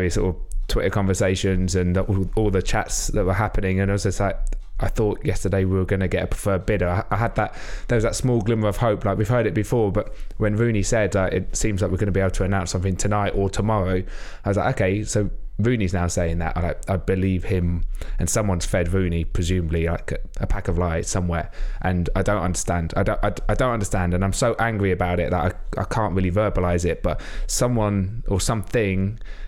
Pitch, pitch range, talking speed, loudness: 95 Hz, 90-105 Hz, 230 wpm, -23 LUFS